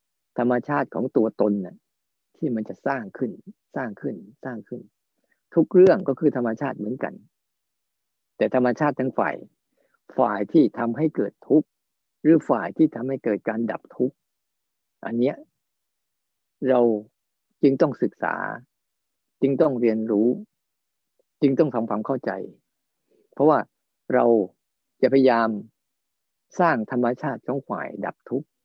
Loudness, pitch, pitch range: -23 LUFS, 125 Hz, 115-145 Hz